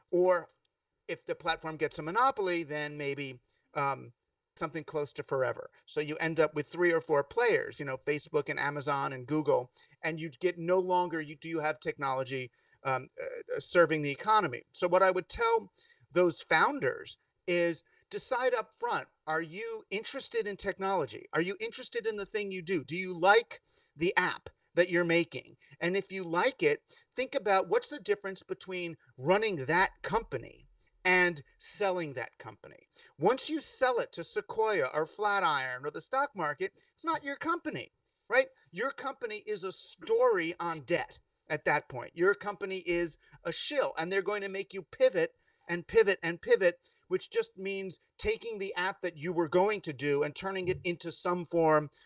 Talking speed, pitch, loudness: 180 wpm, 185 Hz, -32 LUFS